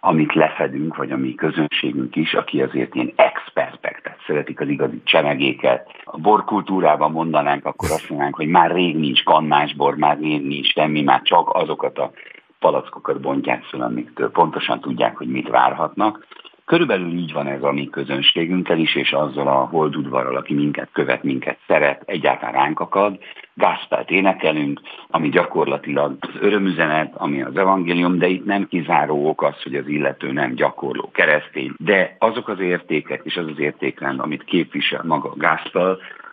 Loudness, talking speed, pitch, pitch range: -19 LUFS, 160 wpm, 80 Hz, 70-90 Hz